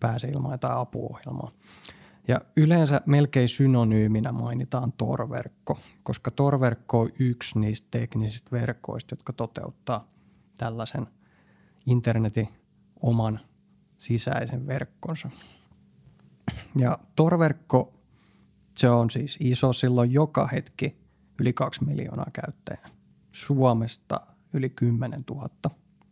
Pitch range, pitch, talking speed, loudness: 115-140 Hz, 125 Hz, 95 wpm, -26 LUFS